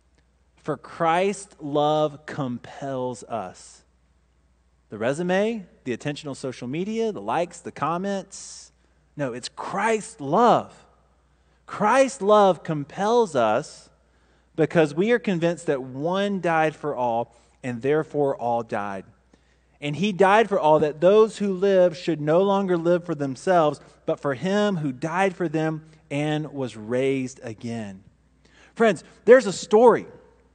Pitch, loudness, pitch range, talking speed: 150 Hz, -23 LUFS, 120-190 Hz, 130 wpm